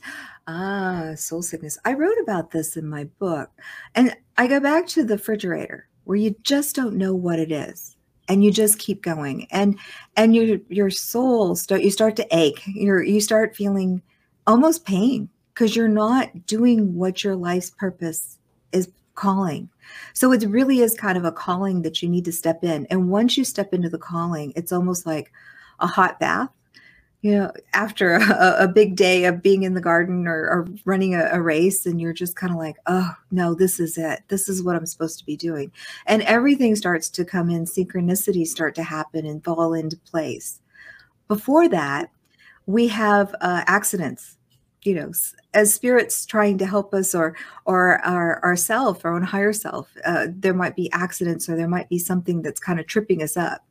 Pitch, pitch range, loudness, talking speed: 185 Hz, 170-210 Hz, -21 LUFS, 195 wpm